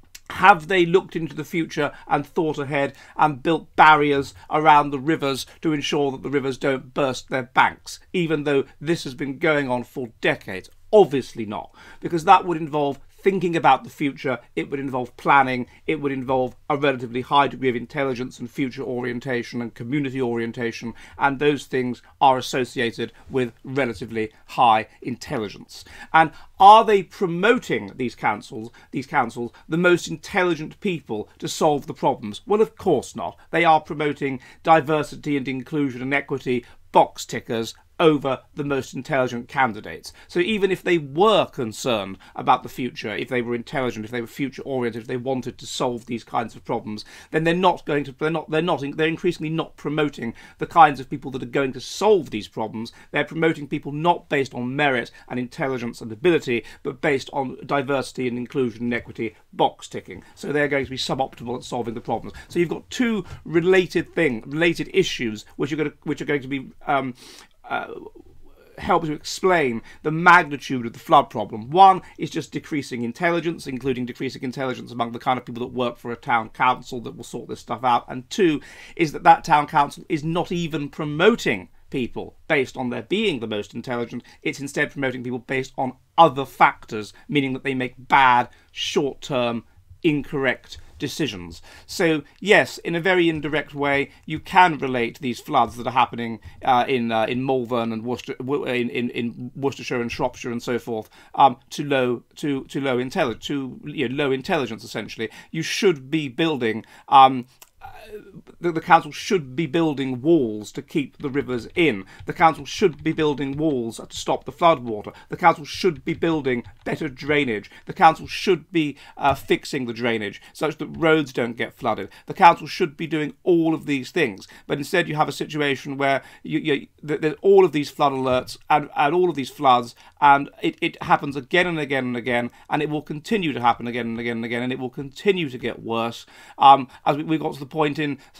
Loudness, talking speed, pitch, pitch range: -22 LUFS, 190 wpm, 140 Hz, 125-155 Hz